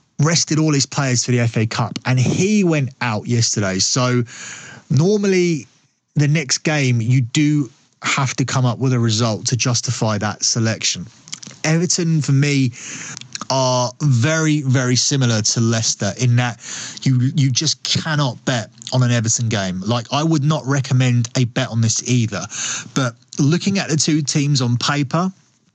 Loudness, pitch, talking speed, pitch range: -18 LUFS, 130 Hz, 160 wpm, 120-150 Hz